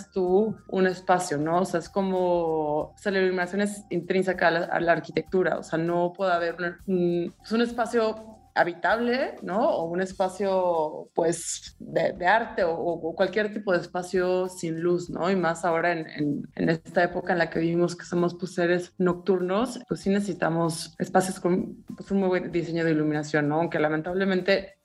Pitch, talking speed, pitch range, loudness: 180 Hz, 190 wpm, 170-190 Hz, -26 LUFS